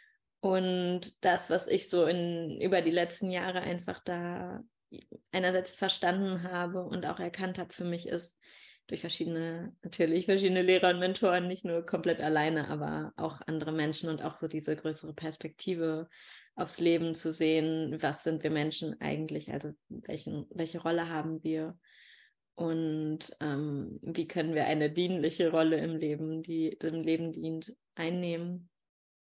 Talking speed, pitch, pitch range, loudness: 150 wpm, 165 Hz, 160-180 Hz, -32 LUFS